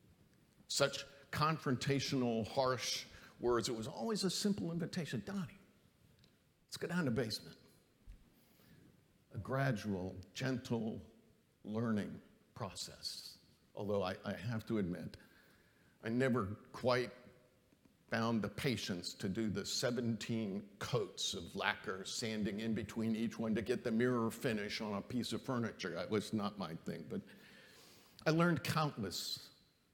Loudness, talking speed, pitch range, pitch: -39 LUFS, 130 wpm, 110-135 Hz, 120 Hz